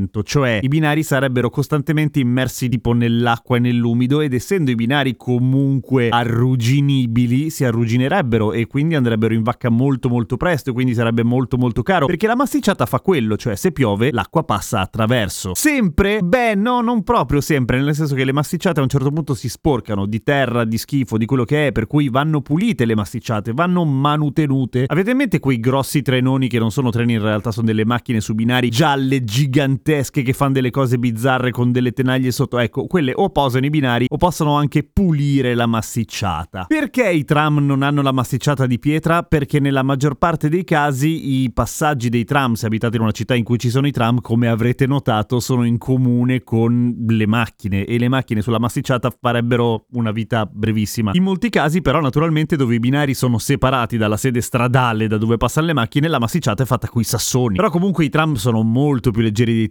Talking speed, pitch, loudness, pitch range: 200 wpm, 130 Hz, -17 LUFS, 120-145 Hz